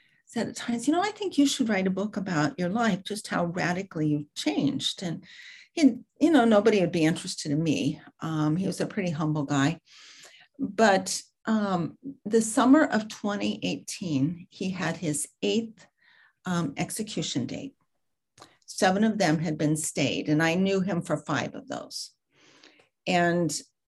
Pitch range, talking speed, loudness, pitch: 160-225 Hz, 165 wpm, -27 LUFS, 185 Hz